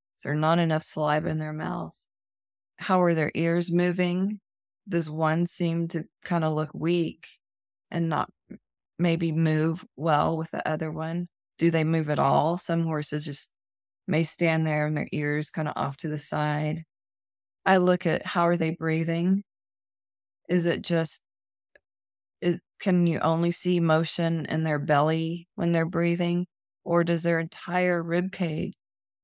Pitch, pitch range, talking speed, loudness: 165 Hz, 150-170 Hz, 160 wpm, -26 LUFS